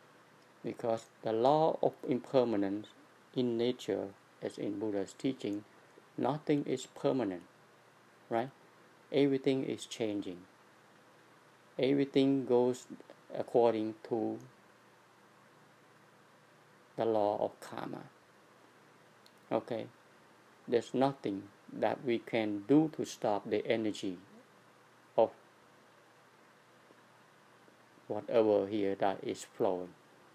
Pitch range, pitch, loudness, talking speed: 105-130 Hz, 115 Hz, -34 LUFS, 85 wpm